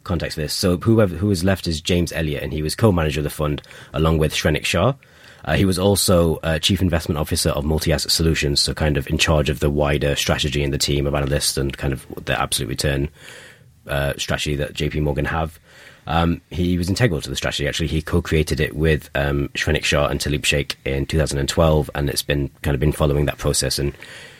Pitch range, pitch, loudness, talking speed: 70-85 Hz, 75 Hz, -20 LUFS, 220 wpm